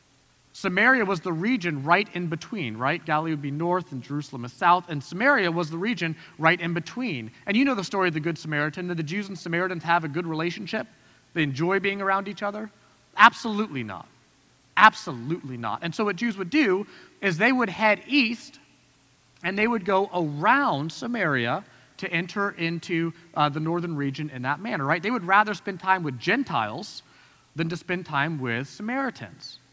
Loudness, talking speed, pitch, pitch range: -25 LUFS, 190 wpm, 175 Hz, 155-205 Hz